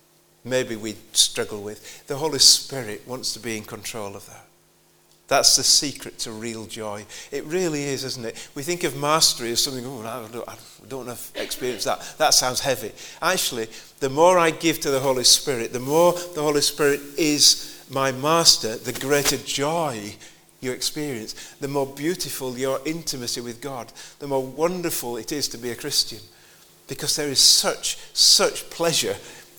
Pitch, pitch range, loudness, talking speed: 135 Hz, 120-150 Hz, -20 LUFS, 175 wpm